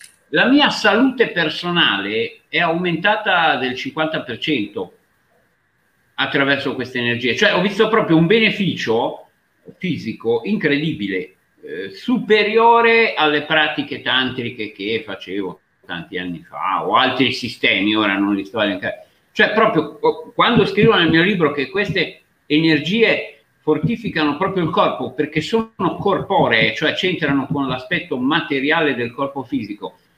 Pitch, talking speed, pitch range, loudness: 160 Hz, 125 wpm, 140-215 Hz, -17 LUFS